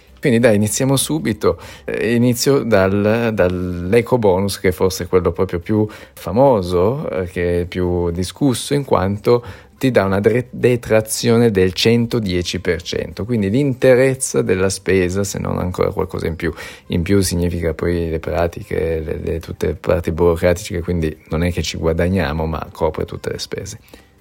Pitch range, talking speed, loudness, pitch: 90-115 Hz, 150 wpm, -17 LUFS, 95 Hz